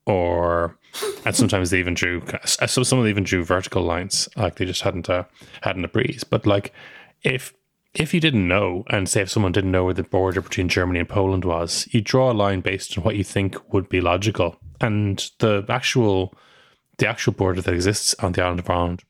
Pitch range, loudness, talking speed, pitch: 90-110 Hz, -21 LUFS, 215 wpm, 95 Hz